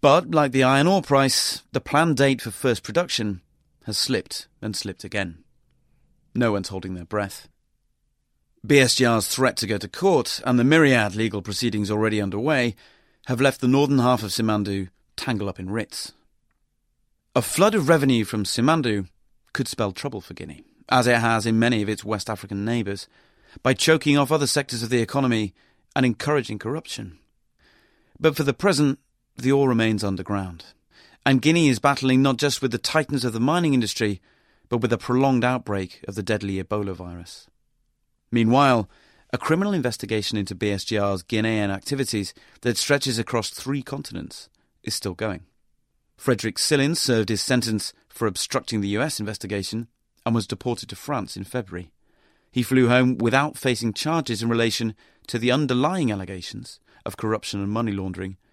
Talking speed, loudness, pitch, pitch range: 165 wpm, -23 LUFS, 115 Hz, 105-135 Hz